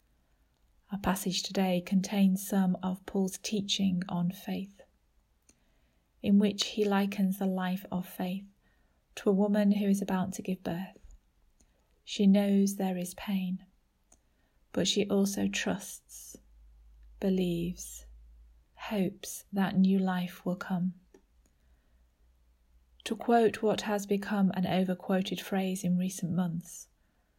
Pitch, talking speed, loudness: 185 Hz, 120 wpm, -31 LUFS